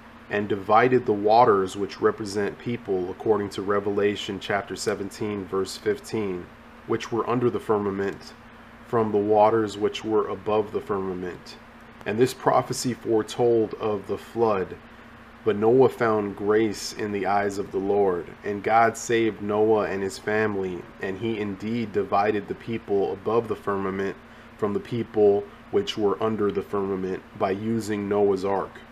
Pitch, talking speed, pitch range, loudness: 105 Hz, 150 wpm, 100-110 Hz, -25 LUFS